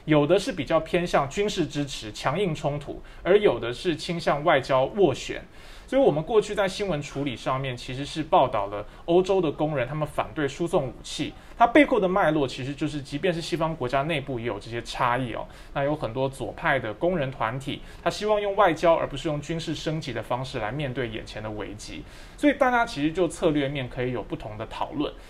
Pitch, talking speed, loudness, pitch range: 150 Hz, 325 characters per minute, -26 LUFS, 130-175 Hz